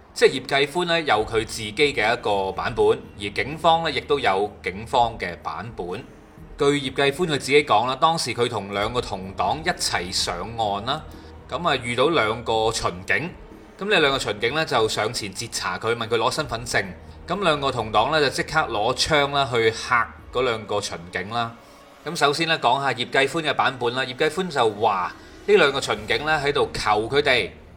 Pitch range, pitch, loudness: 110-155 Hz, 140 Hz, -22 LUFS